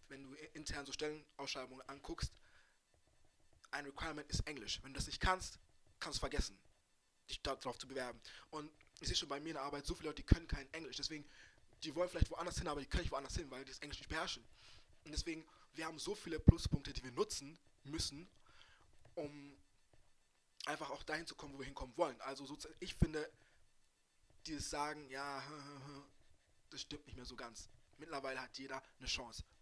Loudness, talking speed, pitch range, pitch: -44 LUFS, 190 wpm, 135-155 Hz, 140 Hz